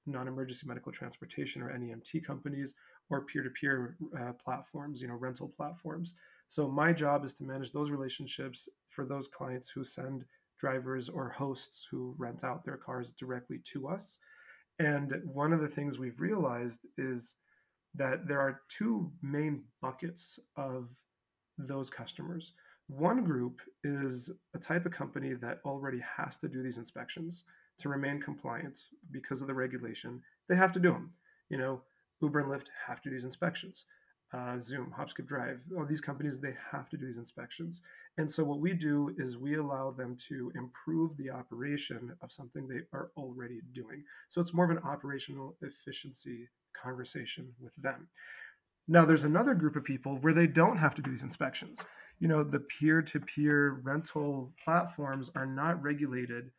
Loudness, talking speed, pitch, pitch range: -35 LUFS, 170 wpm, 140 Hz, 130-160 Hz